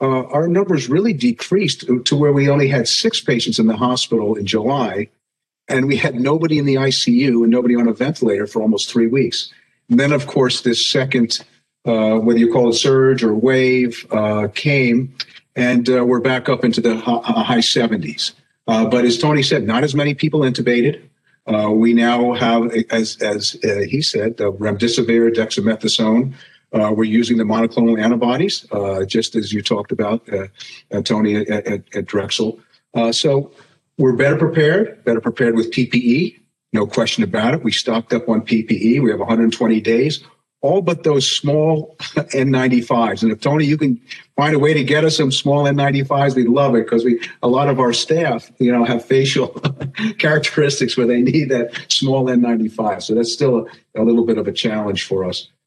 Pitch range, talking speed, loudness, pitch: 115-140 Hz, 190 wpm, -16 LUFS, 125 Hz